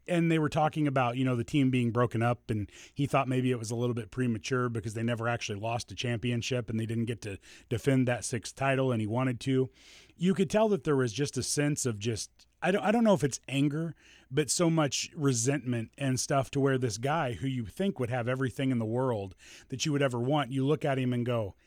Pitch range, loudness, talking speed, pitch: 120-145 Hz, -30 LUFS, 250 wpm, 130 Hz